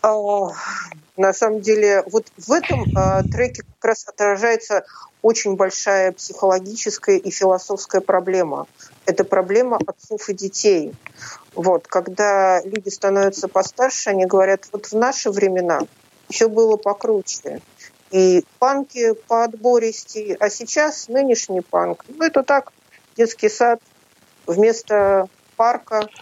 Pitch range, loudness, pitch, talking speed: 190-235 Hz, -19 LUFS, 210 Hz, 120 wpm